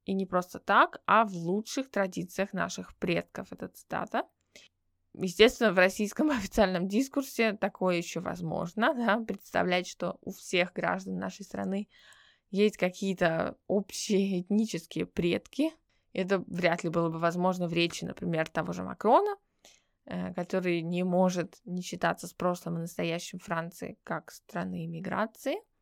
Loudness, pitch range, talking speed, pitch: -30 LUFS, 170-210 Hz, 135 wpm, 185 Hz